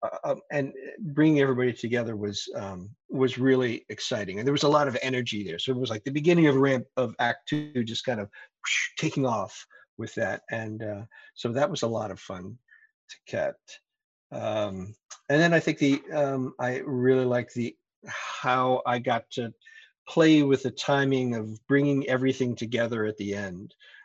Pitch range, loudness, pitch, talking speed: 115-150 Hz, -27 LUFS, 130 Hz, 185 wpm